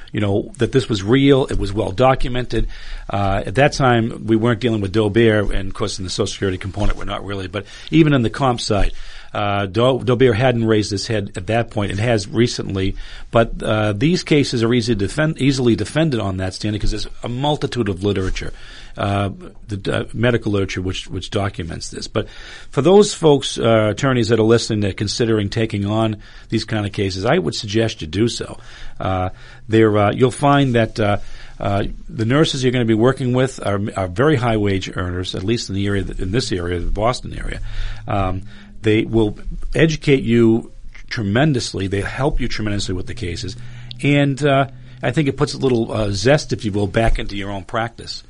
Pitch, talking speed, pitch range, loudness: 110 Hz, 205 wpm, 100-125 Hz, -19 LUFS